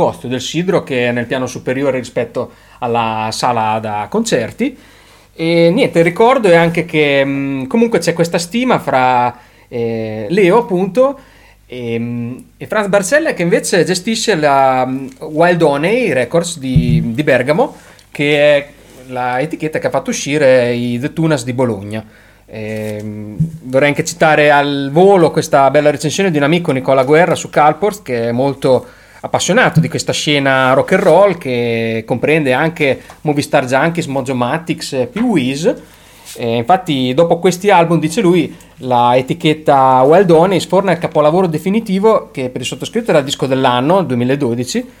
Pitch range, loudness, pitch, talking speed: 125-170 Hz, -13 LUFS, 145 Hz, 150 wpm